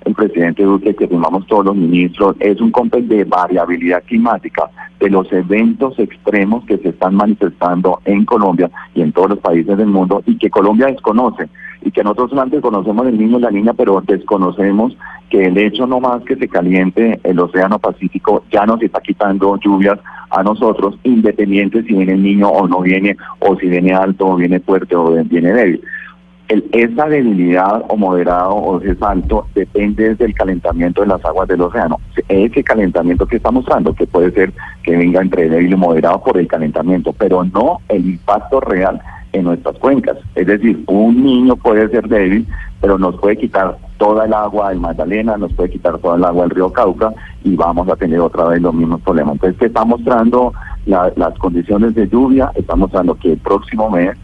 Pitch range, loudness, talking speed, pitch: 90-110 Hz, -13 LUFS, 190 wpm, 100 Hz